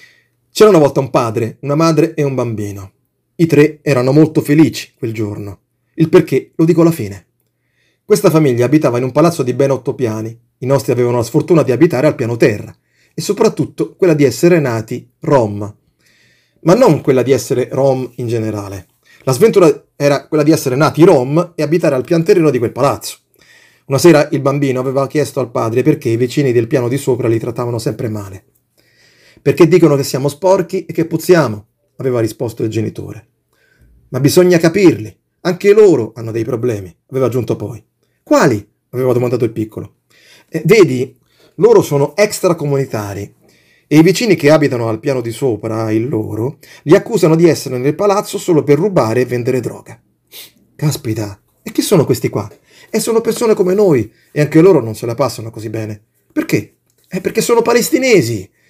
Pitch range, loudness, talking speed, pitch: 120-160 Hz, -13 LUFS, 180 wpm, 140 Hz